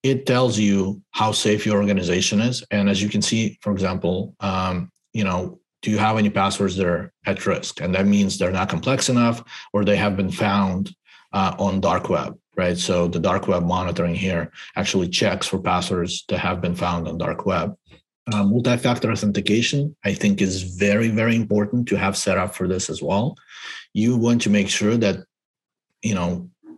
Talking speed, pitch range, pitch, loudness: 195 wpm, 90-110 Hz, 100 Hz, -21 LUFS